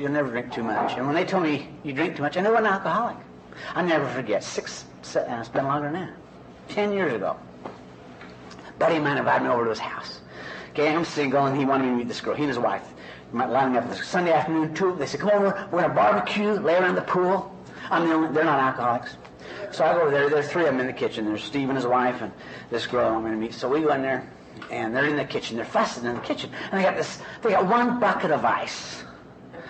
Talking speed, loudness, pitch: 260 wpm, -24 LUFS, 135 Hz